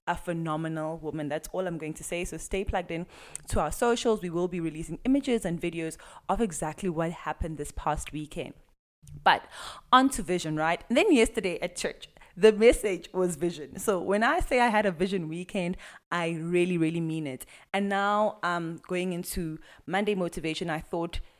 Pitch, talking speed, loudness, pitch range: 175 Hz, 190 wpm, -28 LUFS, 160-195 Hz